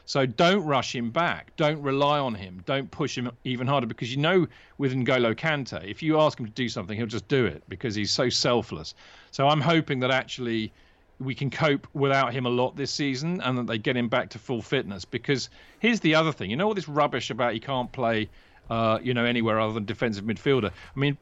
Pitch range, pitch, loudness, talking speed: 115-145 Hz, 130 Hz, -26 LUFS, 230 wpm